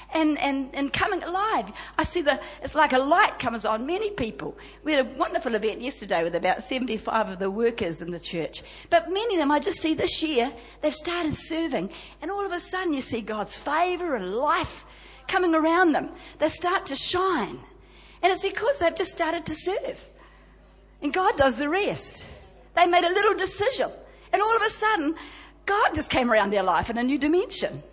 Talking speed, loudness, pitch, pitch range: 205 wpm, -25 LUFS, 325 Hz, 260-370 Hz